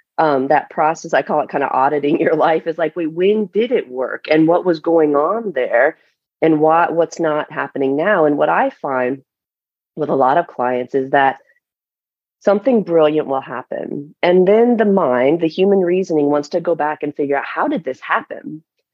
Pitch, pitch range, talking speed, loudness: 160 Hz, 145-180 Hz, 200 wpm, -16 LUFS